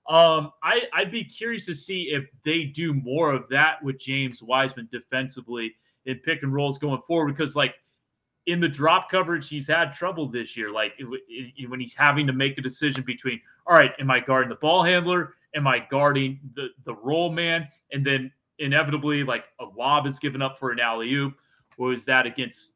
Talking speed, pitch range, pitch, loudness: 205 wpm, 130-160 Hz, 140 Hz, -24 LUFS